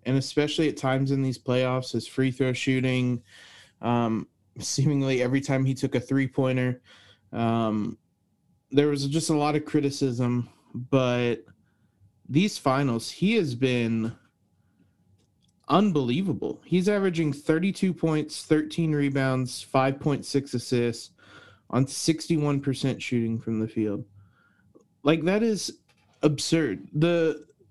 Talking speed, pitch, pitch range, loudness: 115 wpm, 130 Hz, 115-150 Hz, -26 LUFS